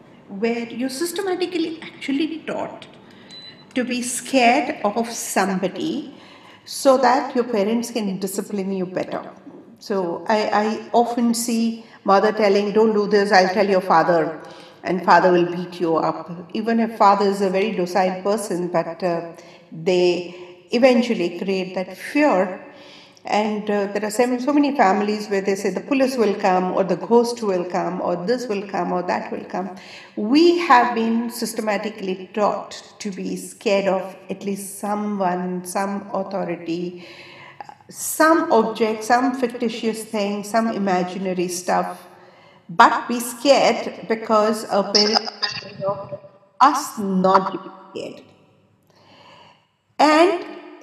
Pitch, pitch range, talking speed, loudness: 205 Hz, 190-235 Hz, 130 wpm, -20 LUFS